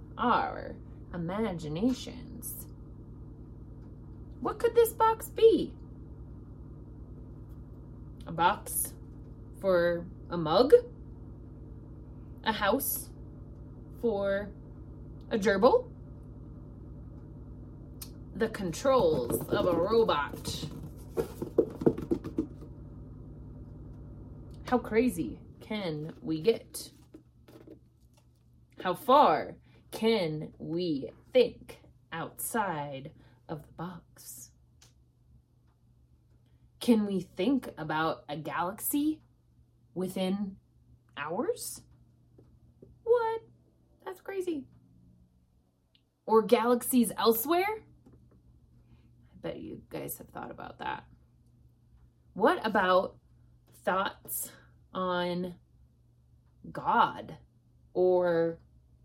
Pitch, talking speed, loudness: 135 Hz, 65 wpm, -30 LUFS